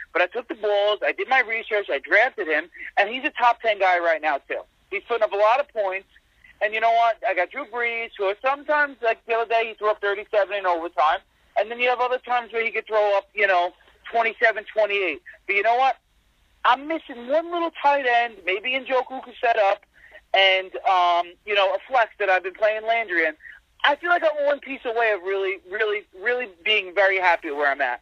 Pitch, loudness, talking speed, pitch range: 225 Hz, -22 LUFS, 230 wpm, 195-250 Hz